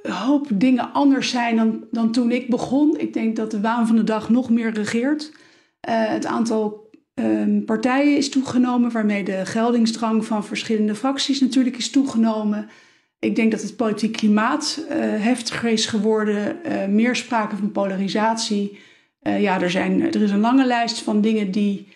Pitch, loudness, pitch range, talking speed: 225 Hz, -20 LUFS, 215-255 Hz, 175 wpm